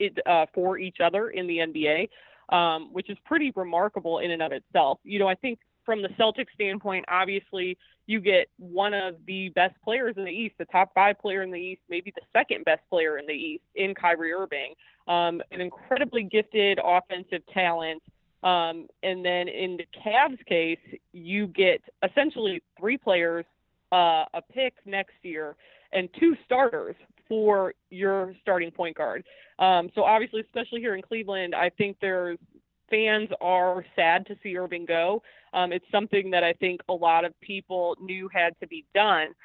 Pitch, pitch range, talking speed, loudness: 185 Hz, 175-210 Hz, 180 wpm, -26 LUFS